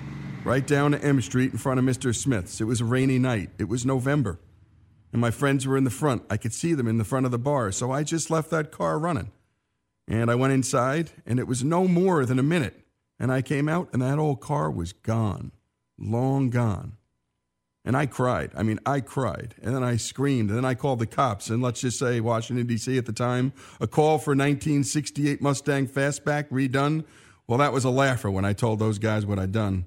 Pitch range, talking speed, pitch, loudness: 110-140 Hz, 225 wpm, 125 Hz, -25 LUFS